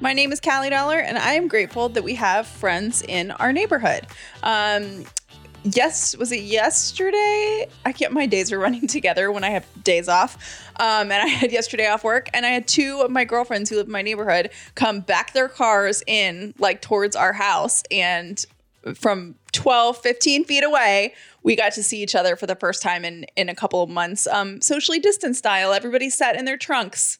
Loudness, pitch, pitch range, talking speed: -20 LUFS, 220 Hz, 200-265 Hz, 205 wpm